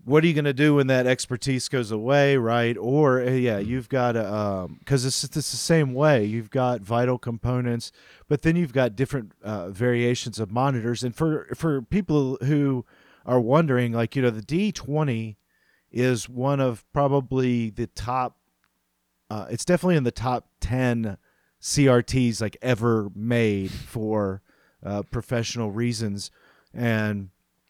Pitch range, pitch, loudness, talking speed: 110-135 Hz, 125 Hz, -24 LUFS, 150 wpm